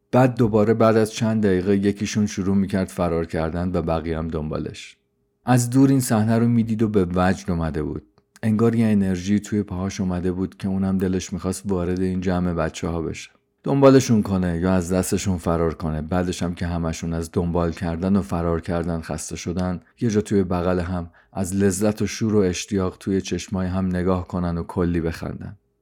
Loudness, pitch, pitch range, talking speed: -22 LUFS, 95 Hz, 85-105 Hz, 190 wpm